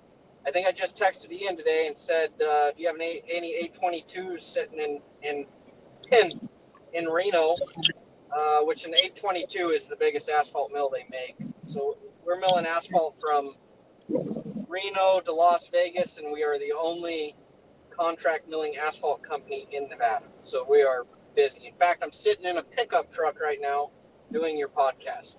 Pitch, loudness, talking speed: 180 Hz, -27 LUFS, 165 wpm